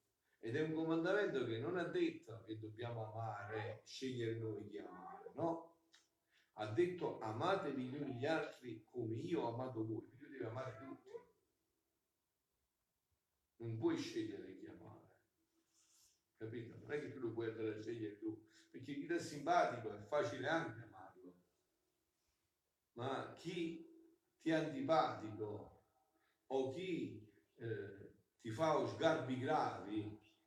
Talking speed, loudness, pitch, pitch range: 130 wpm, -43 LUFS, 145 Hz, 110-185 Hz